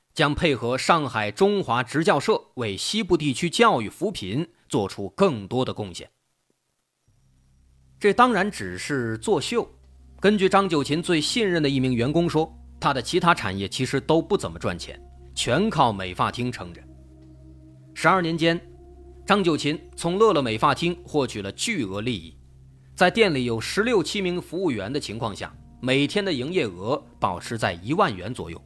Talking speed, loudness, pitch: 245 characters per minute, -23 LUFS, 130 Hz